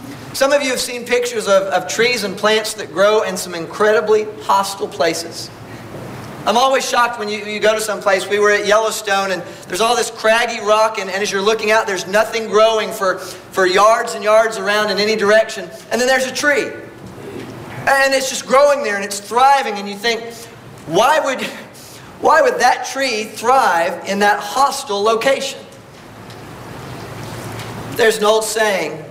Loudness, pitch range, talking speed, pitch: -16 LUFS, 195-235 Hz, 180 wpm, 215 Hz